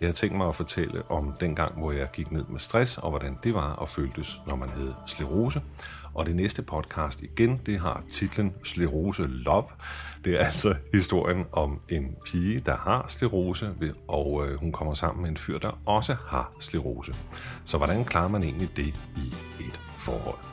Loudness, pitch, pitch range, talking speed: -29 LUFS, 80 Hz, 70-90 Hz, 190 wpm